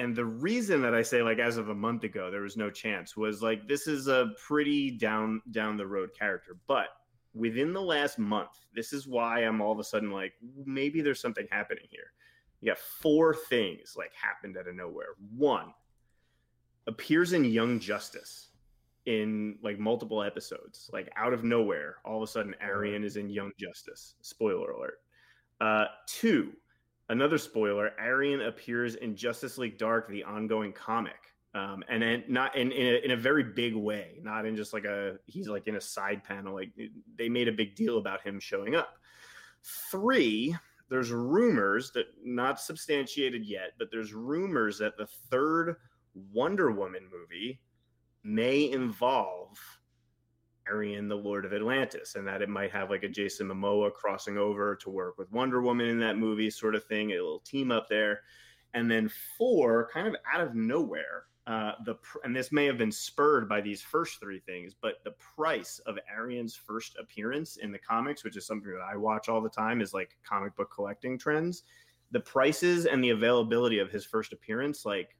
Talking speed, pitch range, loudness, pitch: 185 wpm, 105-130 Hz, -31 LUFS, 115 Hz